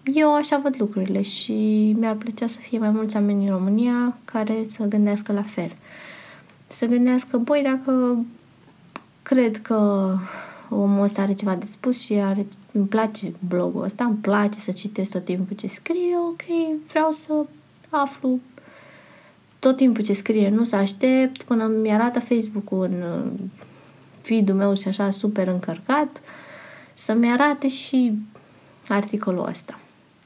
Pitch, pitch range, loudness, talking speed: 220 Hz, 200-255 Hz, -22 LUFS, 140 wpm